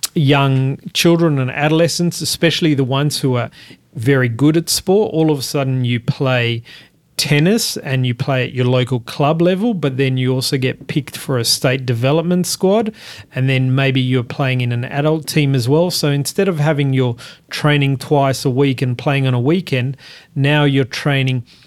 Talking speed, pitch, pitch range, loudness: 185 wpm, 140 Hz, 130-155 Hz, -16 LUFS